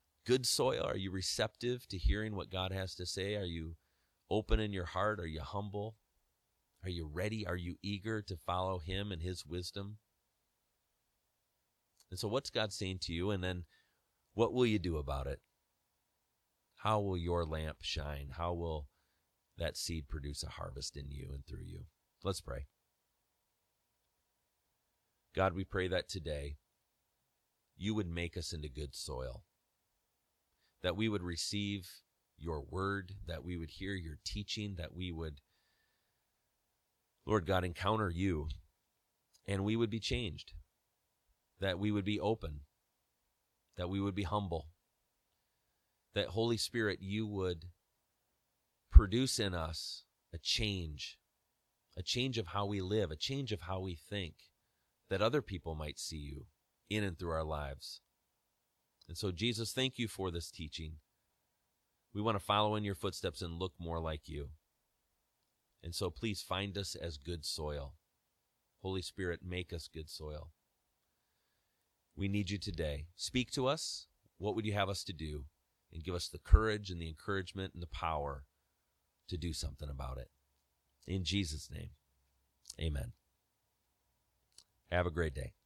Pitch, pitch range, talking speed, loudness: 90 Hz, 80-100 Hz, 155 wpm, -38 LUFS